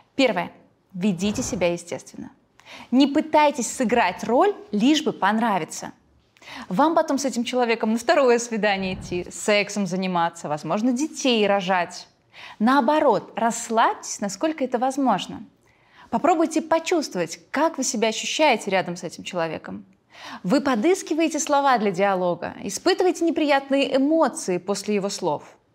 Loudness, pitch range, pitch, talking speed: -22 LUFS, 200-290 Hz, 240 Hz, 120 wpm